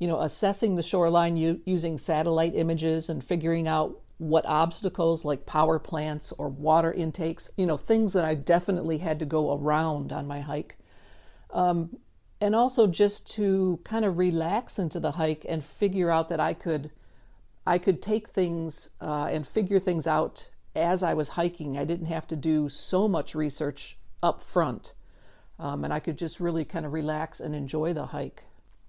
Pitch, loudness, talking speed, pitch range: 165 Hz, -28 LUFS, 180 wpm, 155-180 Hz